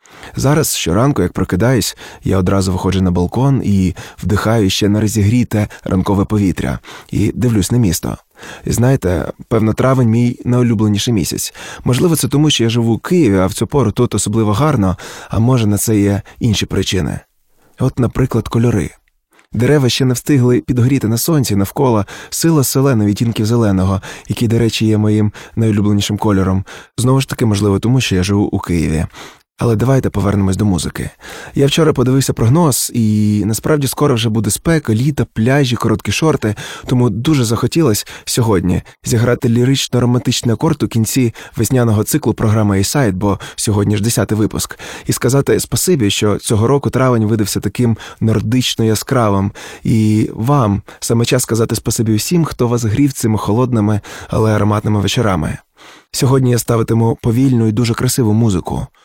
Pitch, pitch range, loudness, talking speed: 115 Hz, 105-125 Hz, -14 LUFS, 155 wpm